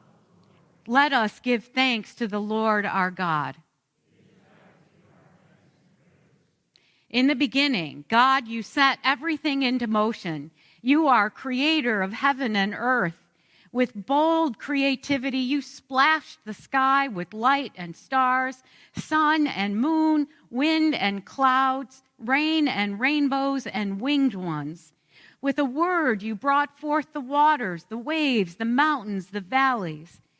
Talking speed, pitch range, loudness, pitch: 120 wpm, 185-275 Hz, -24 LUFS, 245 Hz